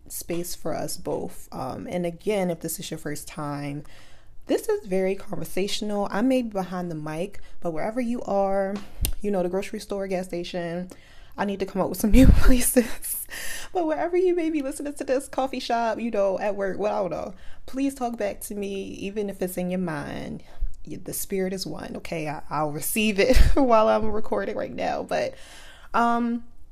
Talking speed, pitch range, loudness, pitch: 200 wpm, 180-235 Hz, -26 LUFS, 200 Hz